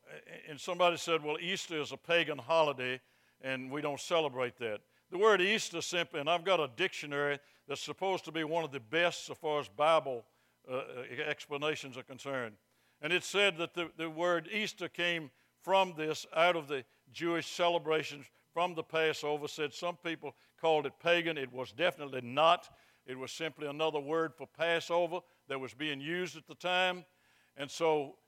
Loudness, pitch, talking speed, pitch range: -34 LUFS, 160 Hz, 180 wpm, 145-170 Hz